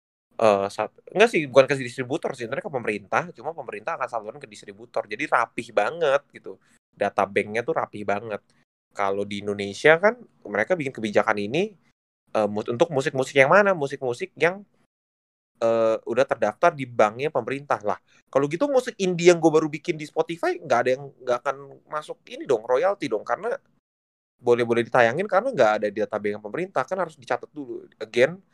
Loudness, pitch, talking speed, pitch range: -24 LUFS, 130 Hz, 175 wpm, 105-170 Hz